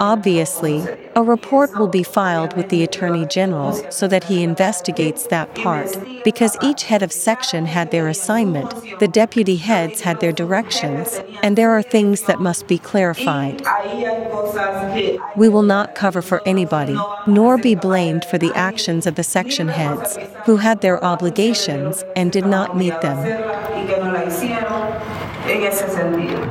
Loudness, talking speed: -18 LUFS, 145 wpm